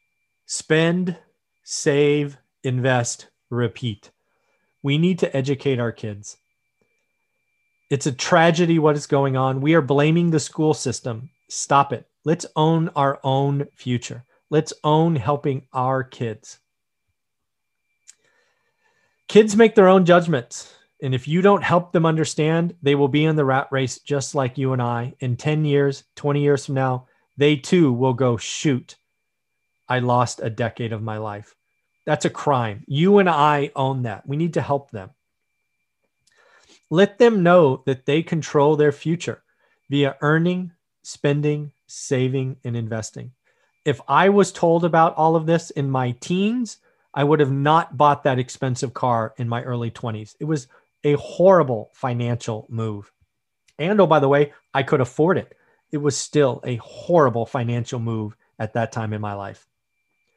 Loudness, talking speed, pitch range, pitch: -20 LUFS, 155 wpm, 125-160 Hz, 140 Hz